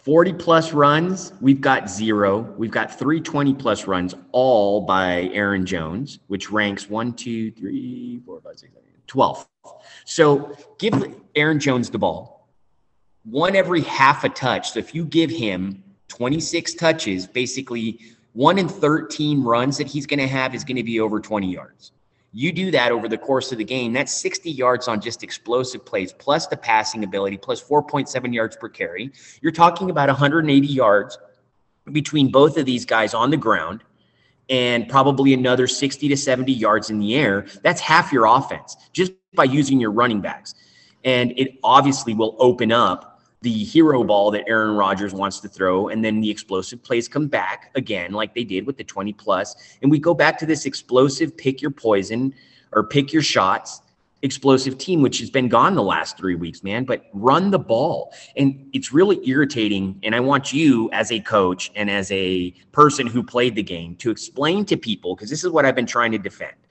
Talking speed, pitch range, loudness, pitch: 190 wpm, 105-150 Hz, -20 LUFS, 125 Hz